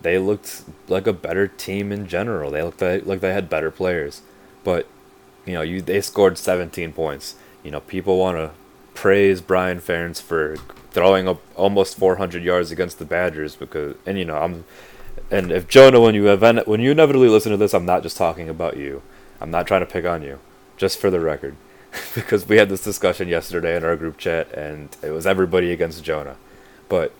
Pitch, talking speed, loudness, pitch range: 90 Hz, 205 wpm, -19 LUFS, 80-100 Hz